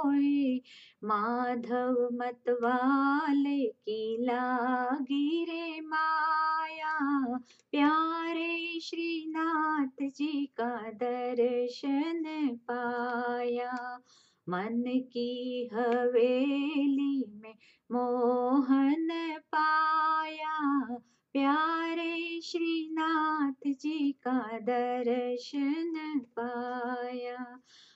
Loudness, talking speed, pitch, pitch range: -31 LUFS, 50 wpm, 270 Hz, 245-310 Hz